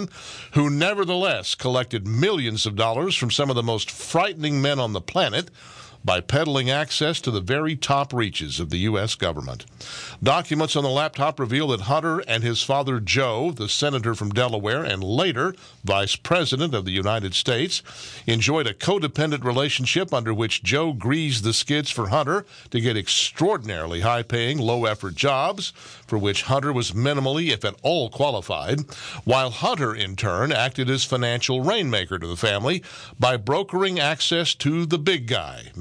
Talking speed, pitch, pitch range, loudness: 165 wpm, 130 Hz, 110-145 Hz, -22 LUFS